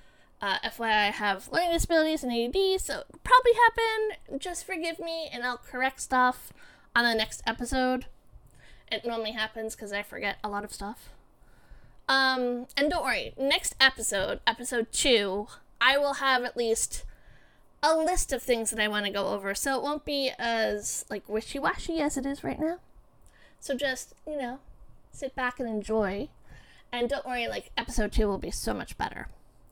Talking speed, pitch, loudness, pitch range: 175 wpm, 250 Hz, -28 LUFS, 220-285 Hz